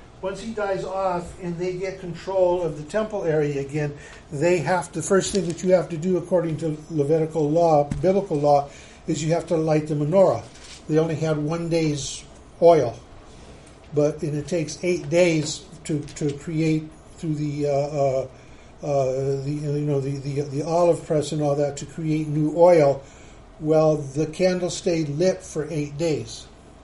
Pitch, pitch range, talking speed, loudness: 155 Hz, 145-175 Hz, 175 wpm, -23 LUFS